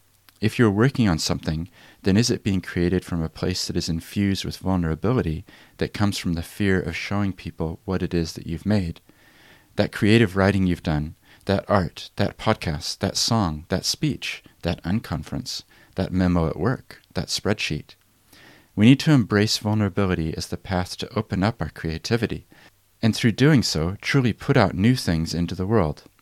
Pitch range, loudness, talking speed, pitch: 85-105 Hz, -23 LUFS, 180 wpm, 95 Hz